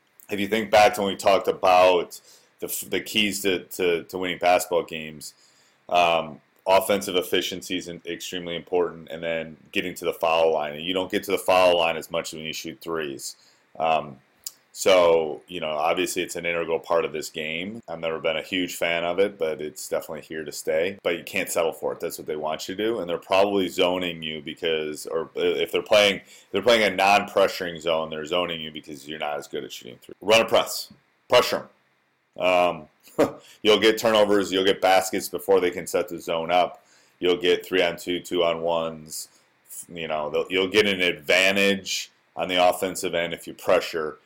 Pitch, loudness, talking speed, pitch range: 90 Hz, -23 LUFS, 205 wpm, 80-100 Hz